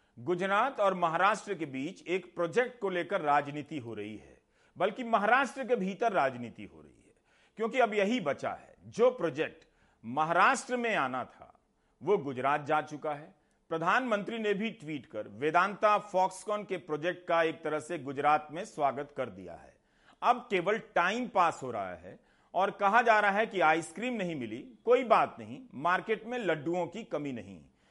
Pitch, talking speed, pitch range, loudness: 185 Hz, 175 wpm, 150-220 Hz, -31 LUFS